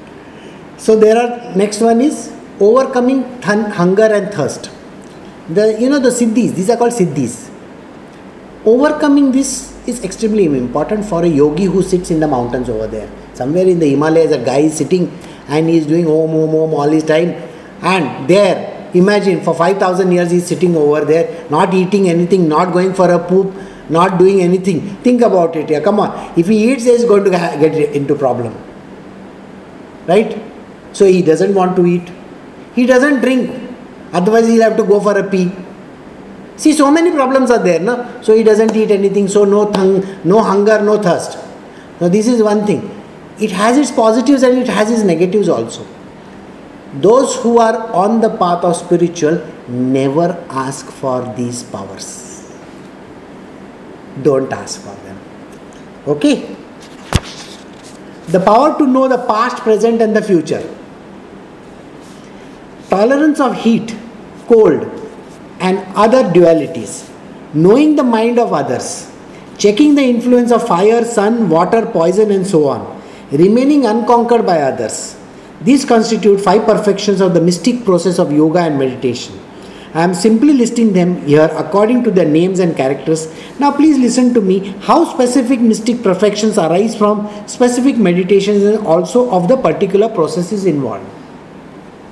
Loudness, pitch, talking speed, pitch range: -12 LUFS, 200 Hz, 160 wpm, 170-230 Hz